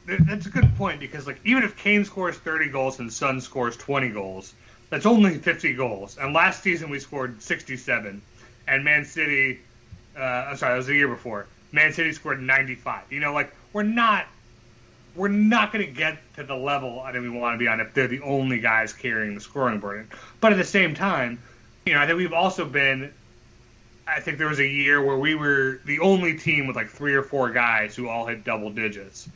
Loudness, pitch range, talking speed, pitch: -23 LUFS, 120-155 Hz, 215 wpm, 135 Hz